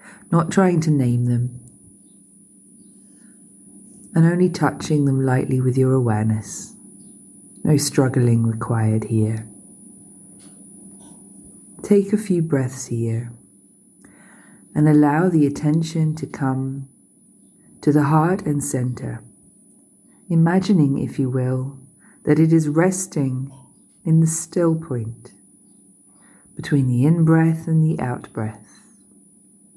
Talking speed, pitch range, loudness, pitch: 105 wpm, 120-160 Hz, -19 LUFS, 140 Hz